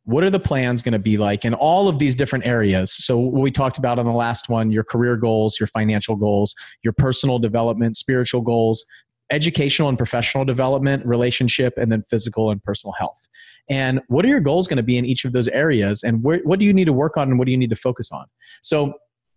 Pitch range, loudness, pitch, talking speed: 115-135 Hz, -19 LUFS, 125 Hz, 235 wpm